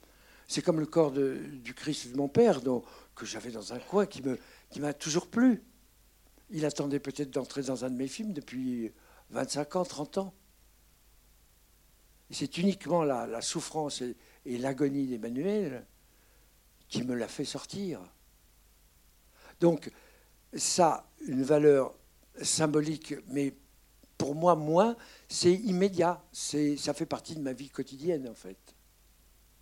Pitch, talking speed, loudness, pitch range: 145 Hz, 145 wpm, -31 LUFS, 125-170 Hz